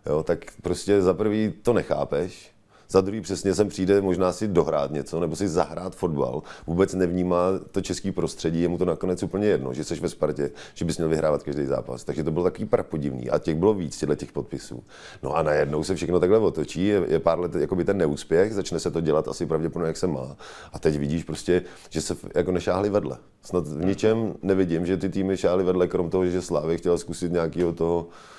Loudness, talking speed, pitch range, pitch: -25 LUFS, 215 wpm, 80-95 Hz, 90 Hz